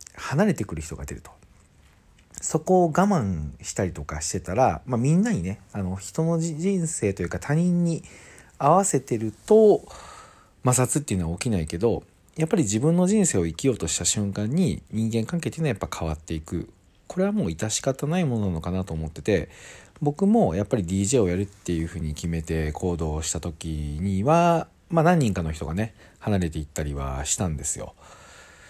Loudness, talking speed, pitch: -24 LUFS, 370 characters per minute, 100 Hz